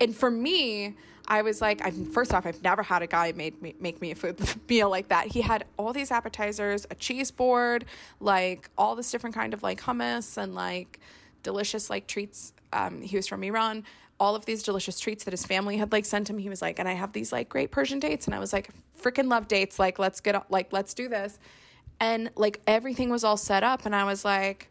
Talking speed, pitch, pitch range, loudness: 240 wpm, 205 Hz, 185-225 Hz, -28 LUFS